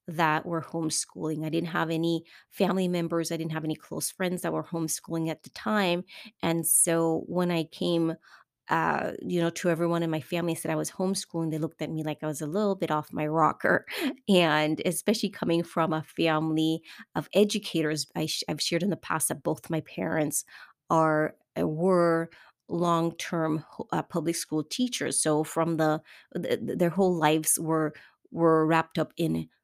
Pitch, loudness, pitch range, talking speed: 165 Hz, -28 LUFS, 155-170 Hz, 185 wpm